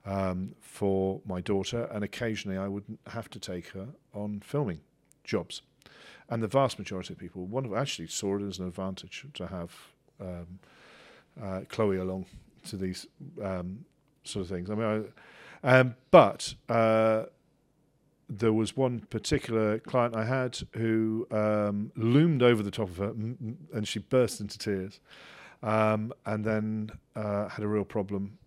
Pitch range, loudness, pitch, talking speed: 95-115 Hz, -30 LUFS, 105 Hz, 160 wpm